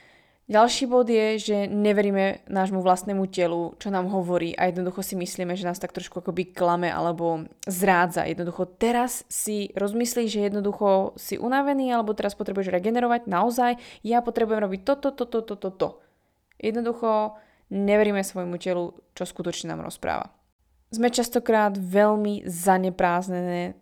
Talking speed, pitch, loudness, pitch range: 140 wpm, 195 Hz, -25 LUFS, 180-220 Hz